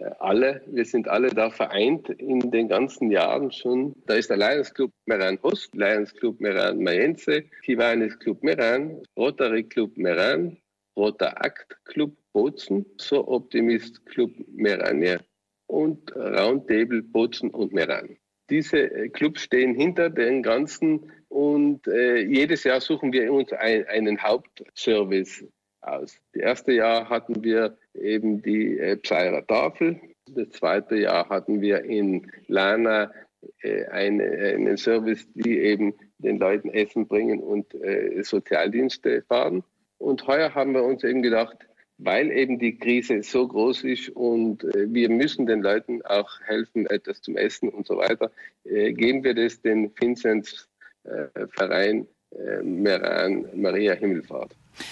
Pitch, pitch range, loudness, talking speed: 120 Hz, 110-145 Hz, -24 LUFS, 140 wpm